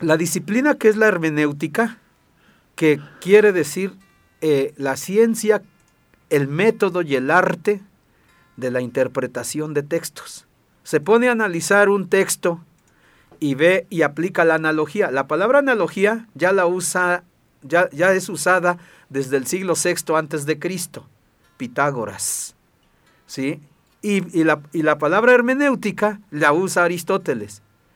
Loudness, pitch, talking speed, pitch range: -19 LUFS, 175 Hz, 135 wpm, 150-200 Hz